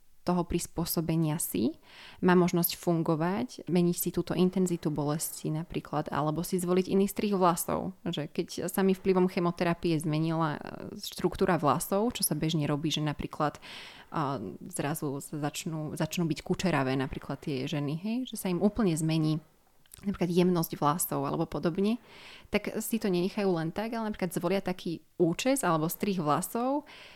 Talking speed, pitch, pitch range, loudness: 150 wpm, 175 Hz, 160-190 Hz, -30 LUFS